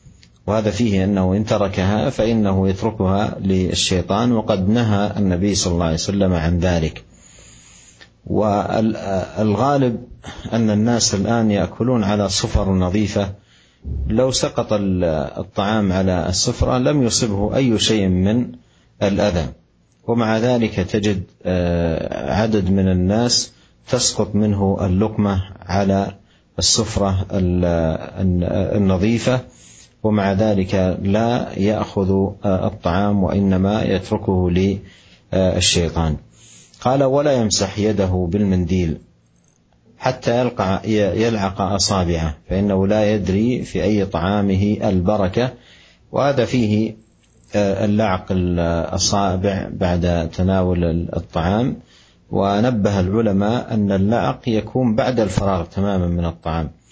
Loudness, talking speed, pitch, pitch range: -18 LUFS, 95 wpm, 100 Hz, 90-110 Hz